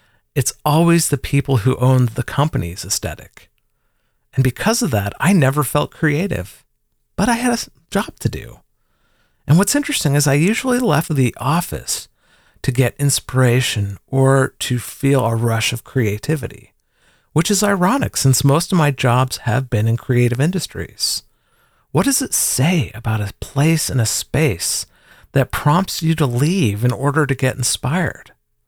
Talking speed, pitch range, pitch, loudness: 160 wpm, 120-160 Hz, 135 Hz, -17 LUFS